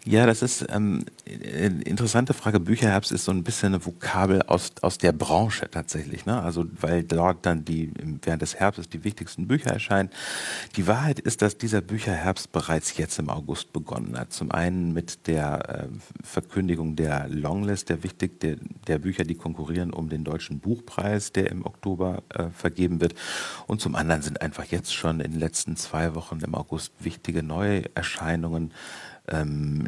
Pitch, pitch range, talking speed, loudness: 90 Hz, 80-100 Hz, 175 wpm, -27 LUFS